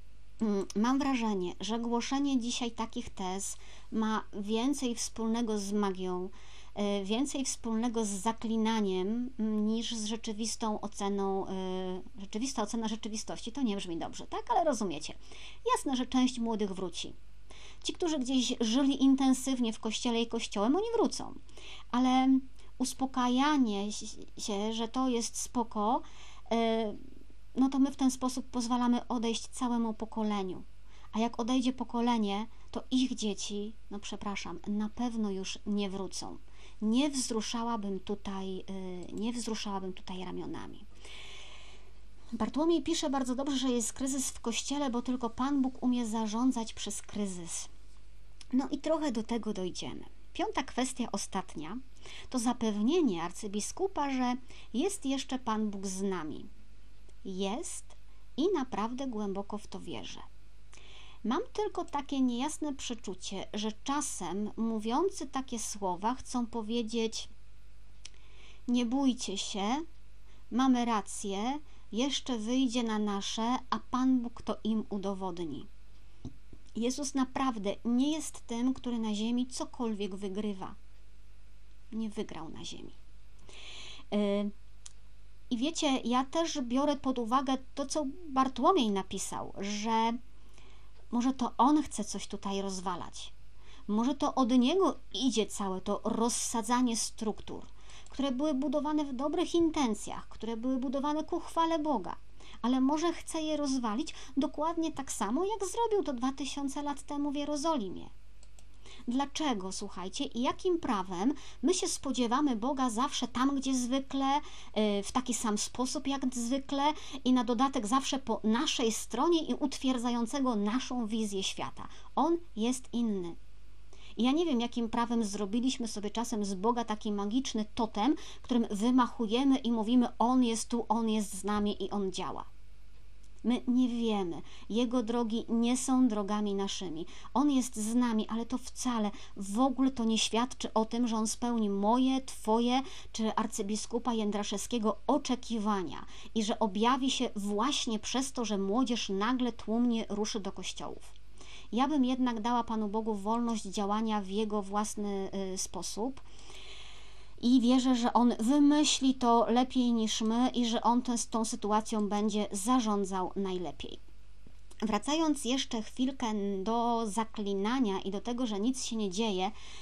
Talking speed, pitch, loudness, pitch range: 135 wpm, 230 Hz, -32 LUFS, 205-260 Hz